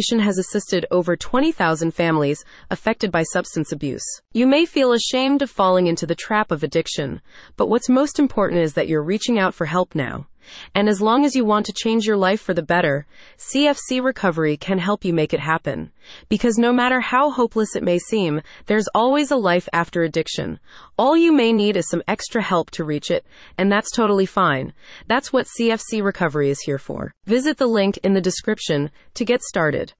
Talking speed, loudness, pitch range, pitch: 195 wpm, -20 LUFS, 170-235 Hz, 200 Hz